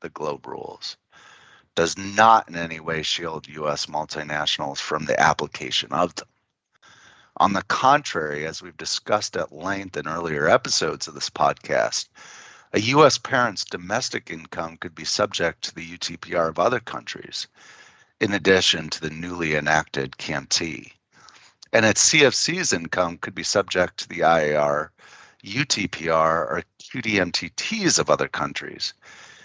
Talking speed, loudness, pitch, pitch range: 135 wpm, -22 LUFS, 80 Hz, 80-95 Hz